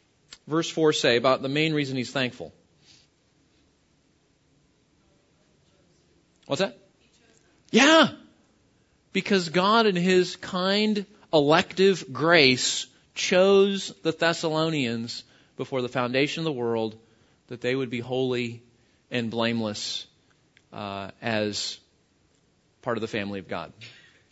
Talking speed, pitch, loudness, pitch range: 105 wpm, 135 Hz, -24 LUFS, 120-180 Hz